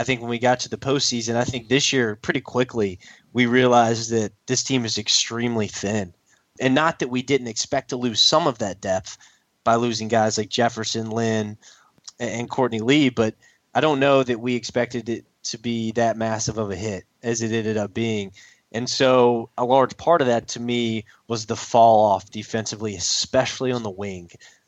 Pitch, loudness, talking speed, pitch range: 115 Hz, -22 LUFS, 195 wpm, 110-125 Hz